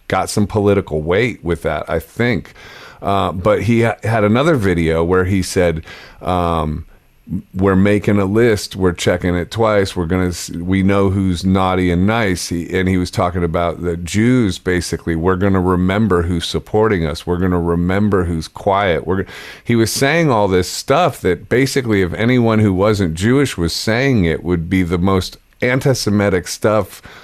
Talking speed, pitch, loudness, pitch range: 185 wpm, 95 Hz, -16 LUFS, 85-105 Hz